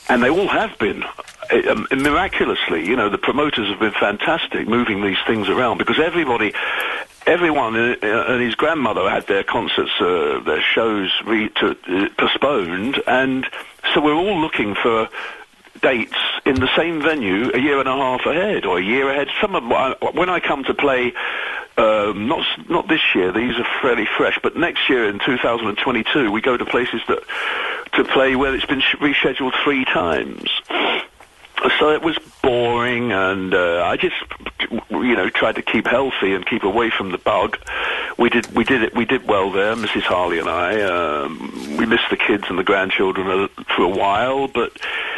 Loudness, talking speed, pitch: -18 LUFS, 180 wpm, 330 Hz